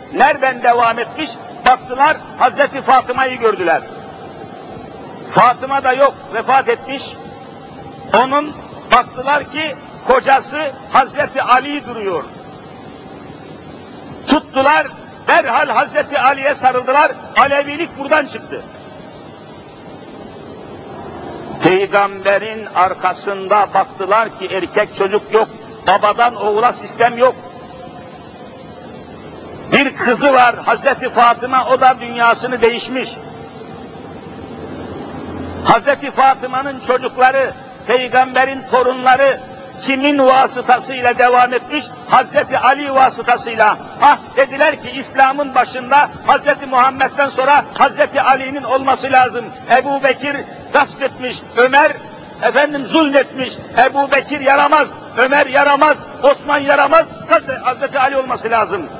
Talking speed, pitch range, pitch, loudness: 90 wpm, 240-280 Hz, 260 Hz, -14 LUFS